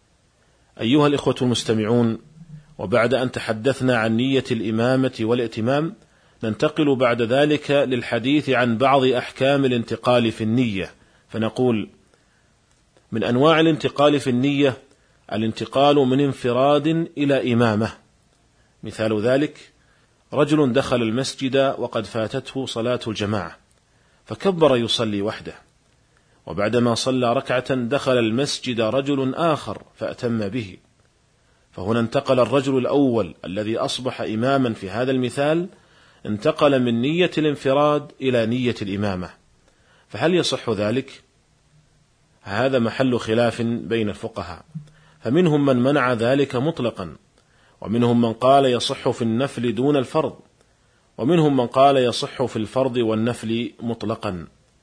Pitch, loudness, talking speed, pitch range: 125 Hz, -21 LUFS, 105 wpm, 115-140 Hz